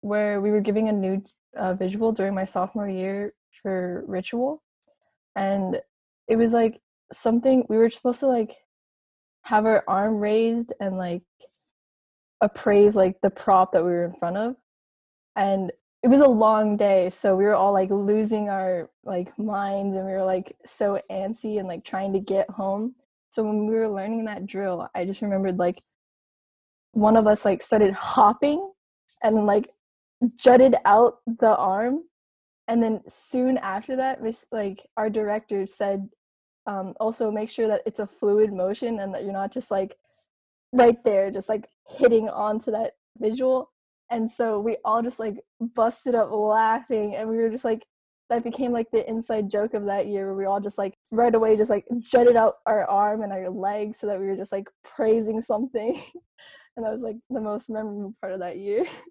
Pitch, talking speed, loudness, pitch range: 215 Hz, 185 wpm, -23 LUFS, 195-230 Hz